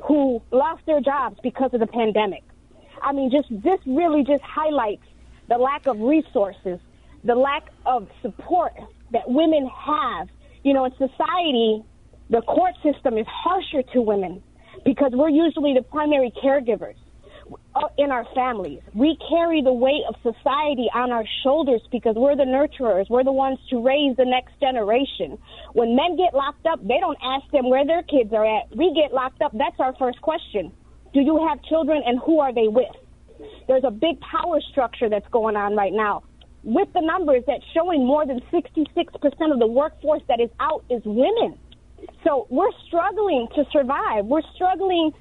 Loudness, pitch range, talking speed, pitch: -21 LUFS, 245-310 Hz, 175 wpm, 275 Hz